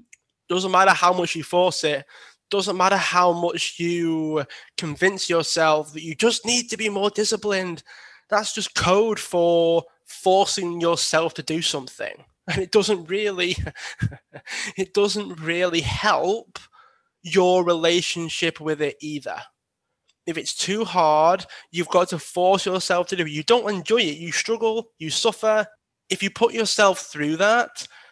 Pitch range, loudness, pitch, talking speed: 165-205 Hz, -22 LUFS, 180 Hz, 150 wpm